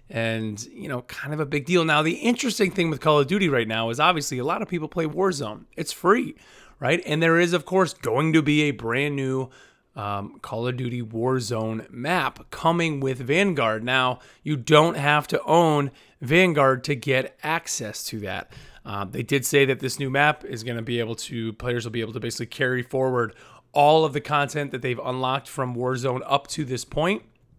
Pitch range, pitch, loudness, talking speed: 120-155 Hz, 135 Hz, -23 LUFS, 210 wpm